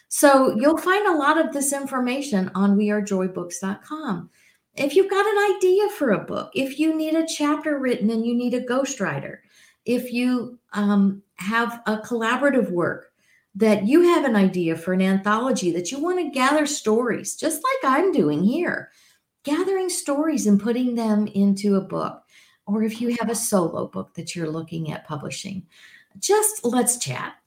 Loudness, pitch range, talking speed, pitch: -22 LUFS, 200-295 Hz, 170 wpm, 240 Hz